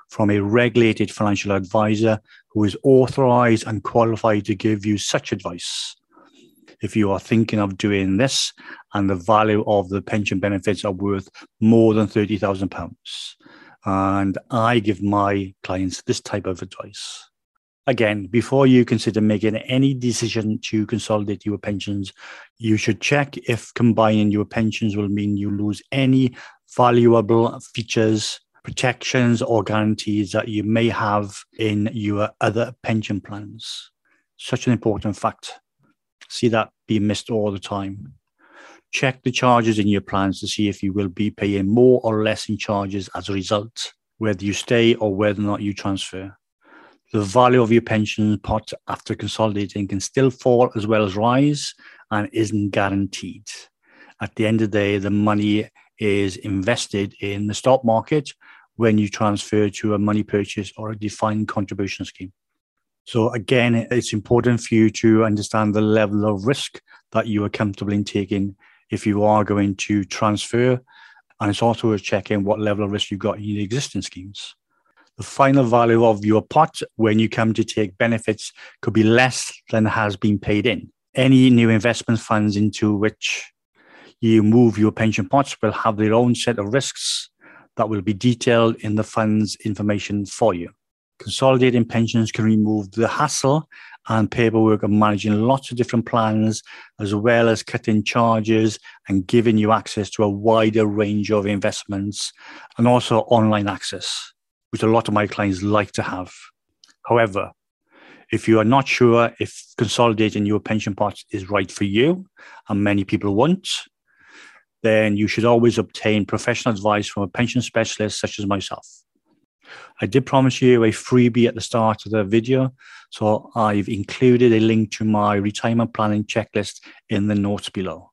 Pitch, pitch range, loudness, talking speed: 110 Hz, 105-115 Hz, -20 LUFS, 165 wpm